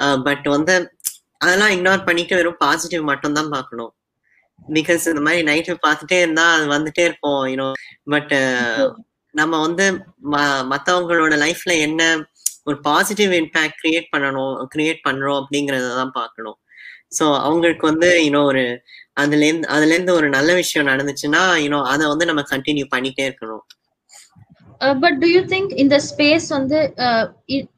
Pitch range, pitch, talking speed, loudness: 145-175 Hz, 155 Hz, 95 wpm, -17 LUFS